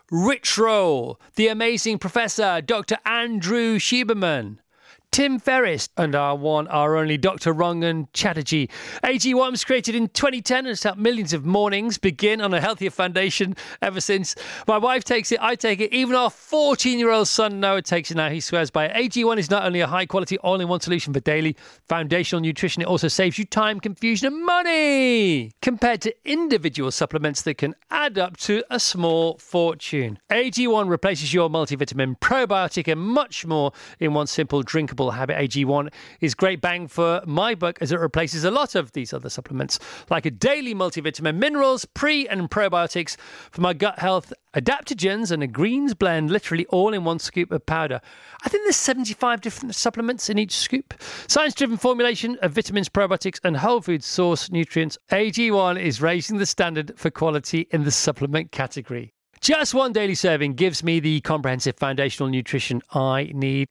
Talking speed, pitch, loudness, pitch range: 175 wpm, 185 Hz, -22 LUFS, 160-230 Hz